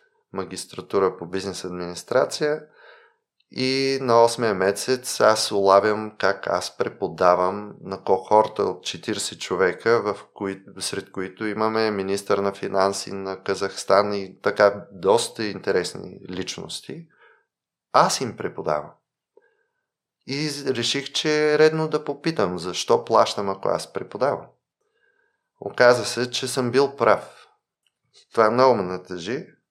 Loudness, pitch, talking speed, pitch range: -22 LUFS, 110 Hz, 115 wpm, 100-145 Hz